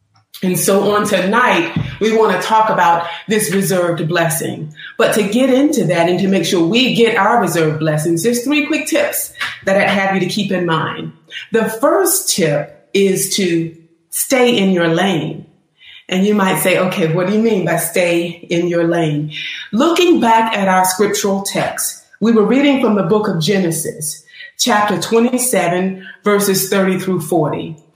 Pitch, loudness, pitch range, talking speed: 190 Hz, -14 LUFS, 170-220 Hz, 175 wpm